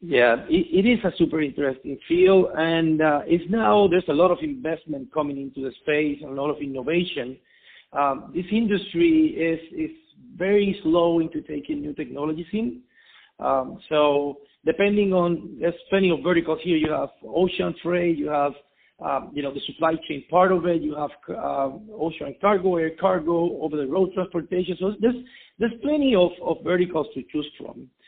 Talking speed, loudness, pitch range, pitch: 175 wpm, -23 LUFS, 150-190 Hz, 170 Hz